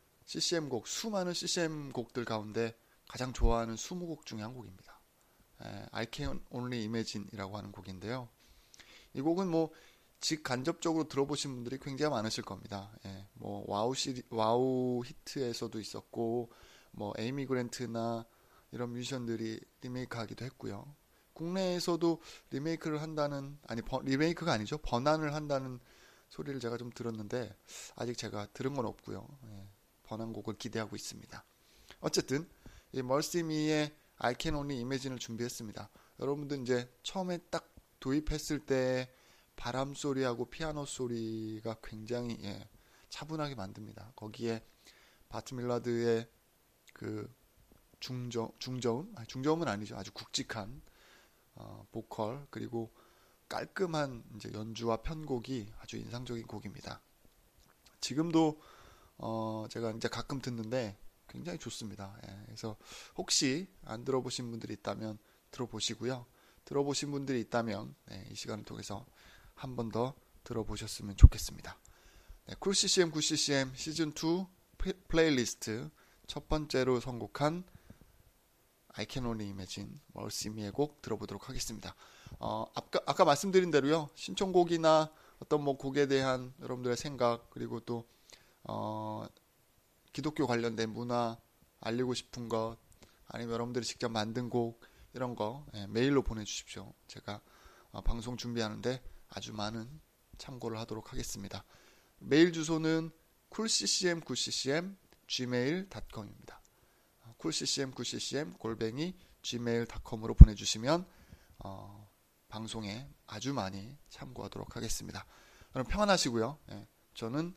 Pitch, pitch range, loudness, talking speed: 120 Hz, 110-145 Hz, -35 LUFS, 305 characters per minute